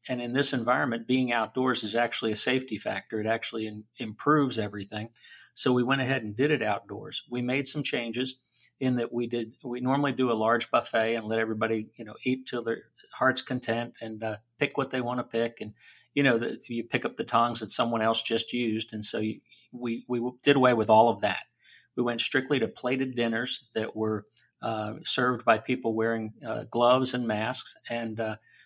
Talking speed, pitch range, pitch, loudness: 210 wpm, 110-125 Hz, 120 Hz, -28 LUFS